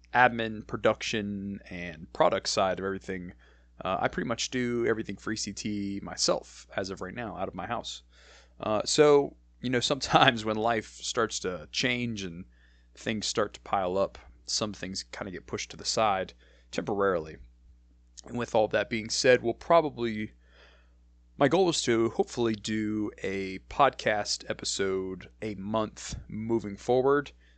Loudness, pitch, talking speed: -29 LUFS, 100 Hz, 155 wpm